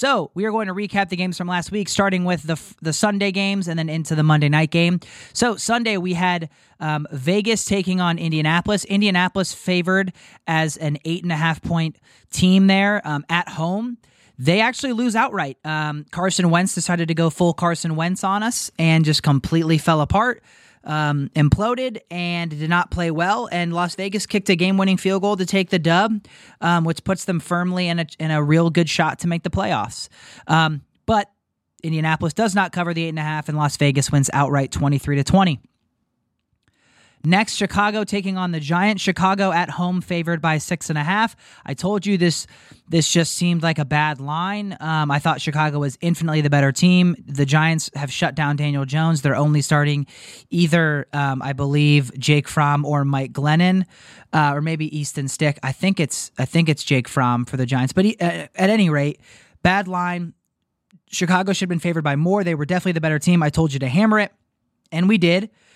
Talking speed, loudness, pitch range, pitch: 205 wpm, -20 LUFS, 150-190 Hz, 170 Hz